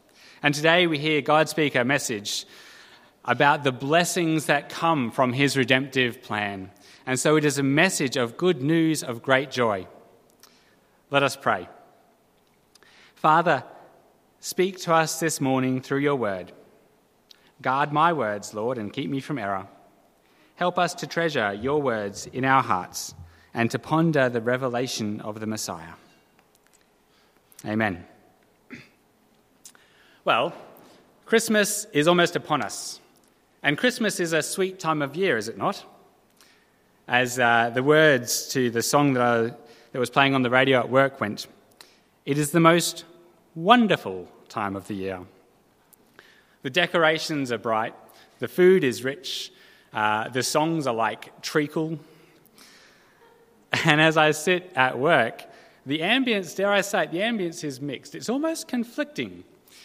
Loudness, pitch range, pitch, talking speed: -23 LUFS, 120-165 Hz, 140 Hz, 140 wpm